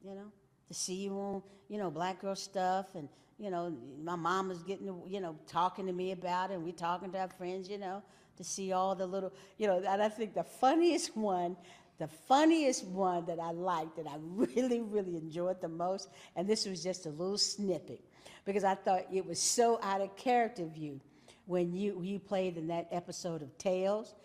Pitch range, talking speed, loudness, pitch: 175-195 Hz, 215 wpm, -35 LUFS, 185 Hz